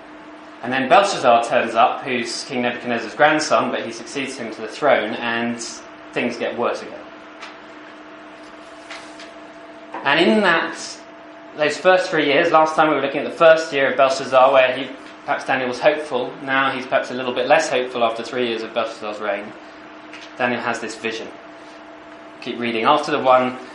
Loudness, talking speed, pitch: -19 LUFS, 170 wpm, 135 Hz